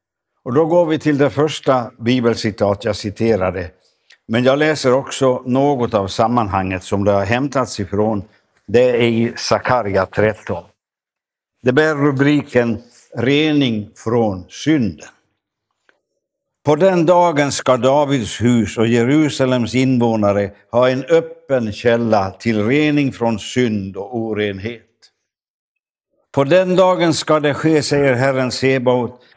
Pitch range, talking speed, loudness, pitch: 110-145 Hz, 125 wpm, -16 LUFS, 125 Hz